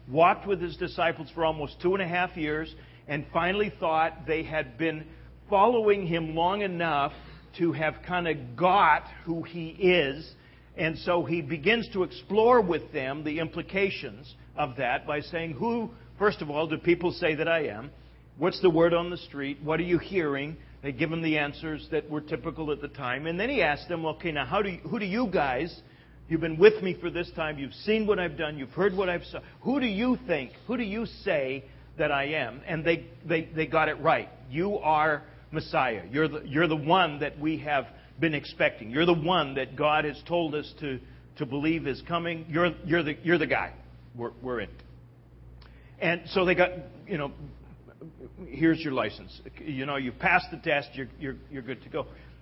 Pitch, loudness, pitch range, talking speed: 160 Hz, -28 LUFS, 145-175 Hz, 205 wpm